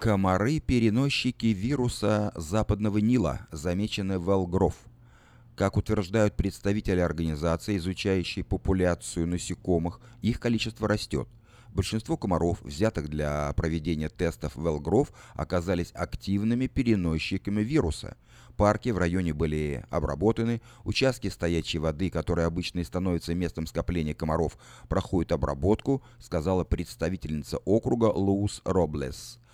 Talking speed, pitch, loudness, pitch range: 105 wpm, 95 Hz, -28 LUFS, 85-110 Hz